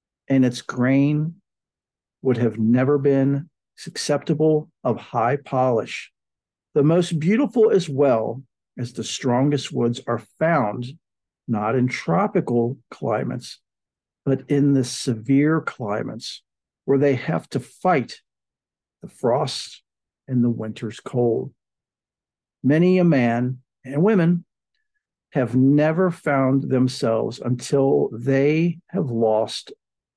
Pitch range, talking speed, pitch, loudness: 120-155 Hz, 110 wpm, 135 Hz, -21 LUFS